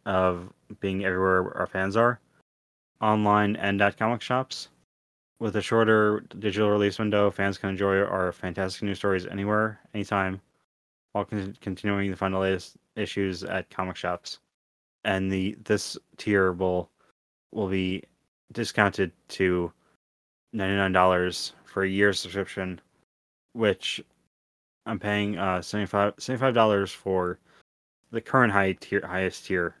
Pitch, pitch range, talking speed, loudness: 95 Hz, 90-105 Hz, 135 wpm, -26 LUFS